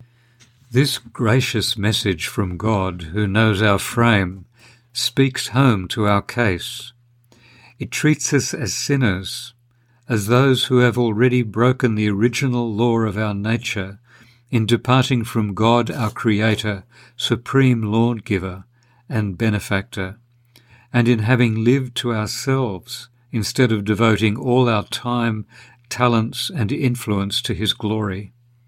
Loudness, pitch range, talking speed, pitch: -19 LUFS, 105-125 Hz, 125 wpm, 120 Hz